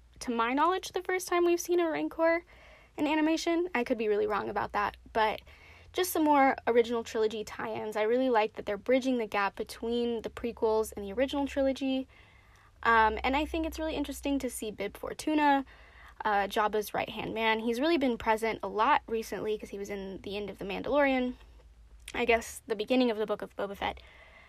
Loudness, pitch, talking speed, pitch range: -30 LUFS, 235 Hz, 205 wpm, 220-285 Hz